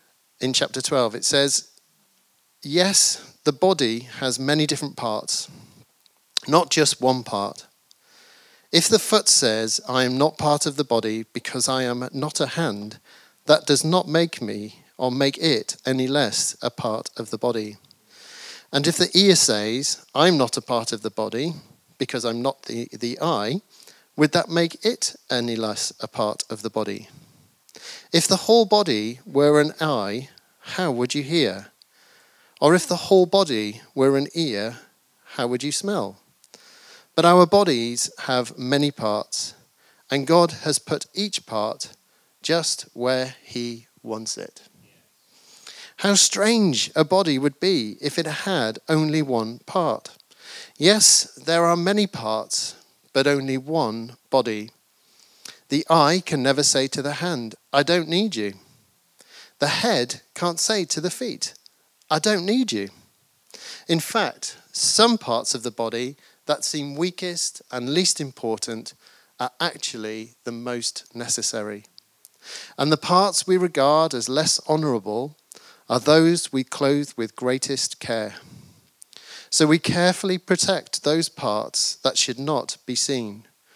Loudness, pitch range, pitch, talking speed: -21 LUFS, 120-170 Hz, 145 Hz, 145 wpm